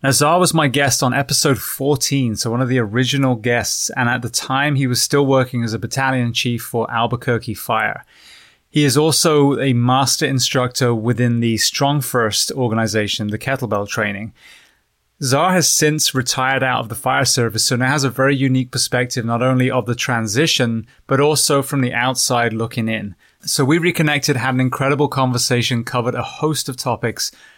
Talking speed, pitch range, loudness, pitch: 180 wpm, 120-140 Hz, -17 LUFS, 130 Hz